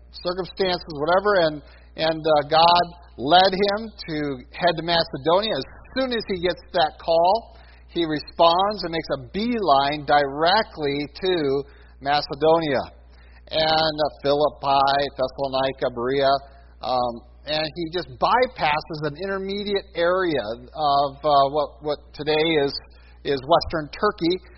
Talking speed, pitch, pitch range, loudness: 120 wpm, 155 Hz, 140-175 Hz, -22 LUFS